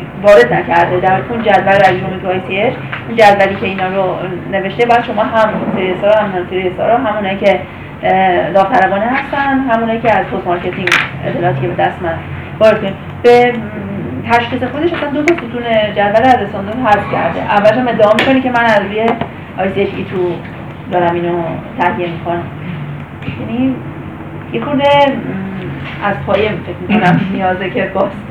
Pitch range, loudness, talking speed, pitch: 185-230 Hz, -13 LUFS, 165 wpm, 200 Hz